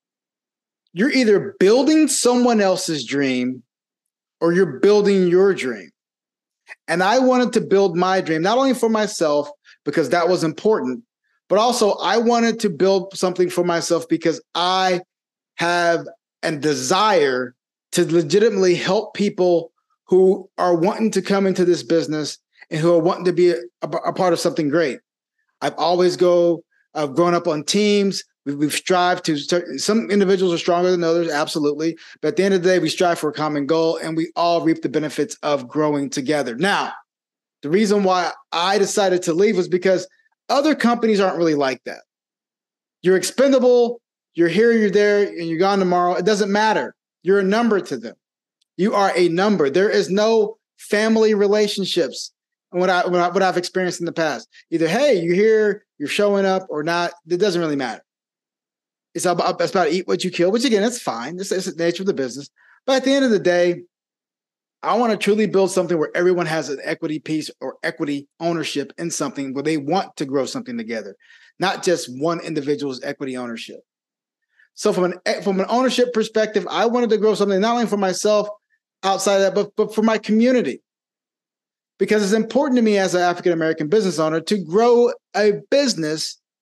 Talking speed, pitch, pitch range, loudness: 185 wpm, 185 Hz, 165-210 Hz, -19 LUFS